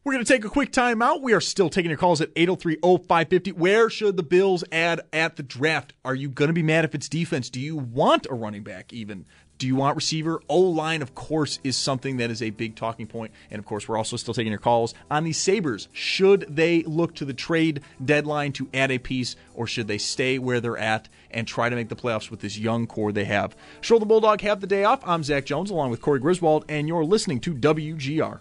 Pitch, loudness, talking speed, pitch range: 150 Hz, -23 LUFS, 245 wpm, 120-170 Hz